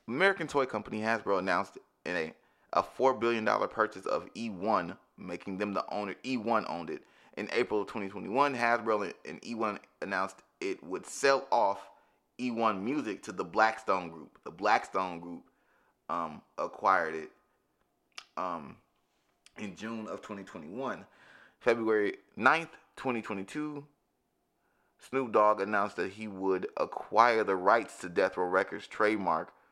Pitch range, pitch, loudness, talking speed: 95-125 Hz, 110 Hz, -31 LUFS, 135 wpm